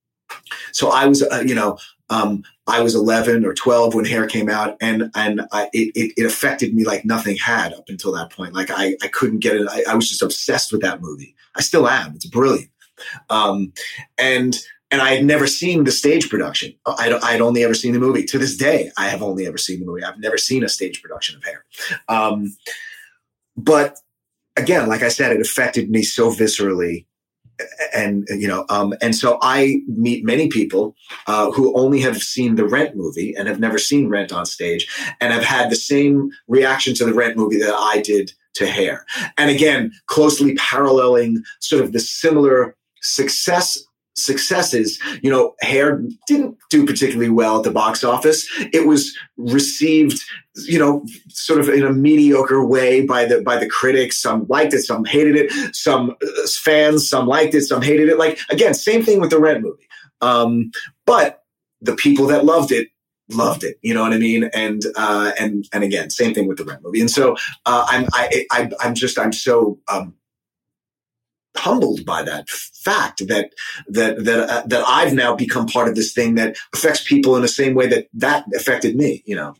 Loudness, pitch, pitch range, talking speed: -17 LUFS, 125 Hz, 110-145 Hz, 195 wpm